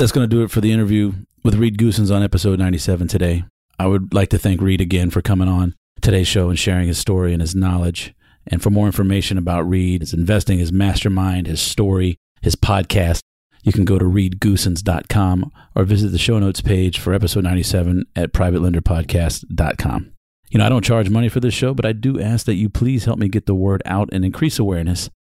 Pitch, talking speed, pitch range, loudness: 95 Hz, 210 wpm, 90-105 Hz, -18 LUFS